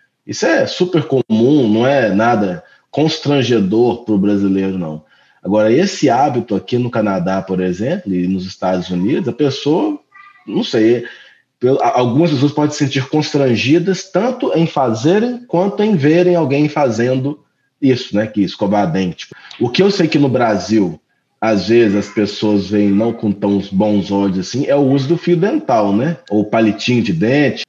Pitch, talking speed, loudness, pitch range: 125 Hz, 165 wpm, -15 LUFS, 100-160 Hz